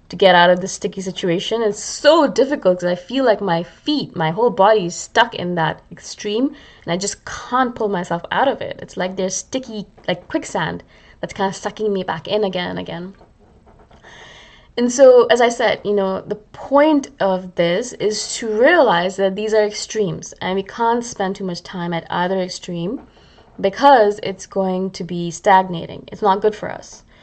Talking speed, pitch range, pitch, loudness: 195 wpm, 185-225 Hz, 195 Hz, -18 LUFS